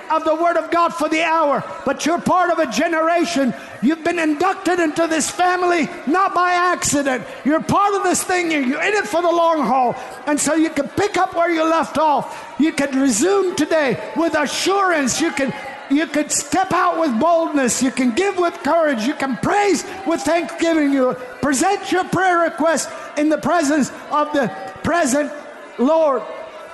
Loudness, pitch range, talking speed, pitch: -18 LUFS, 285-345 Hz, 185 wpm, 320 Hz